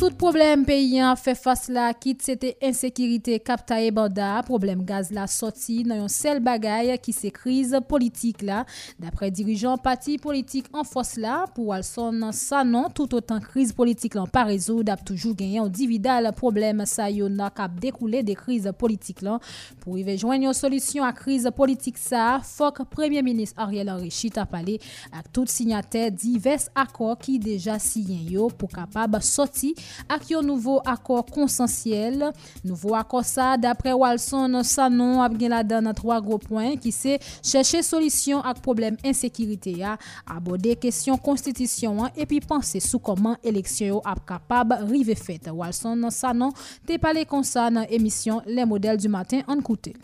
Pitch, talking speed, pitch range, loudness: 235 Hz, 140 wpm, 215-260 Hz, -24 LUFS